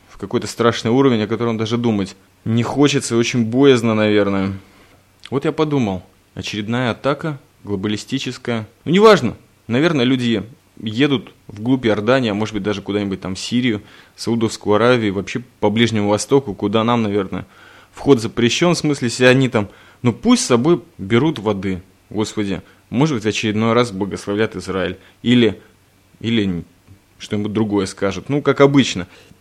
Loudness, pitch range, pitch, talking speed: -18 LUFS, 100-125 Hz, 110 Hz, 150 wpm